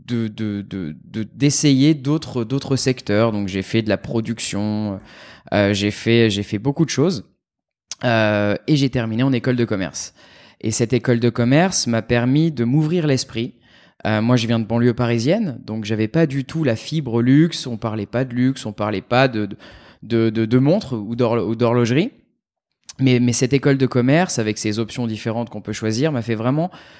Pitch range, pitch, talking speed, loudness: 110-135 Hz, 120 Hz, 200 wpm, -19 LUFS